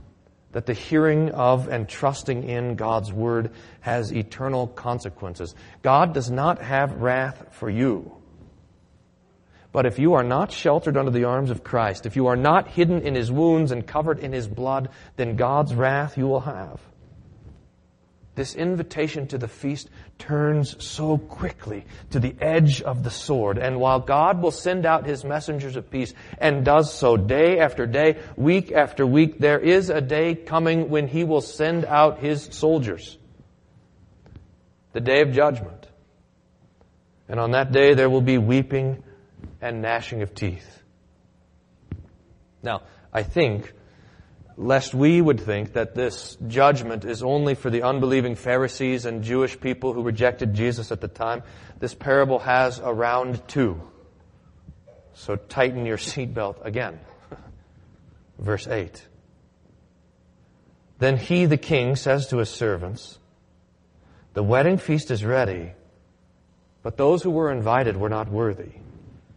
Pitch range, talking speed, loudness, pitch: 110-145 Hz, 145 wpm, -22 LUFS, 125 Hz